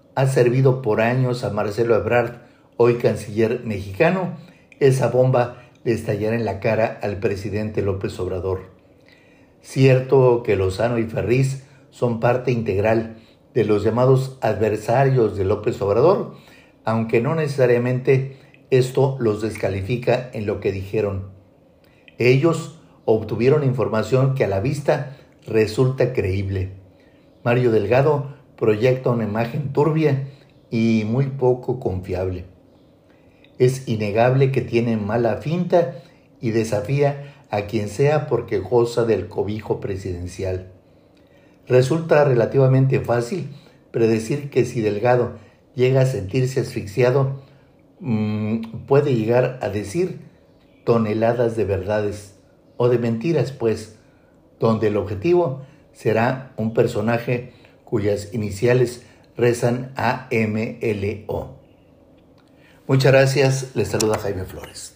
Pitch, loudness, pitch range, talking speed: 120 Hz, -20 LUFS, 110-135 Hz, 115 wpm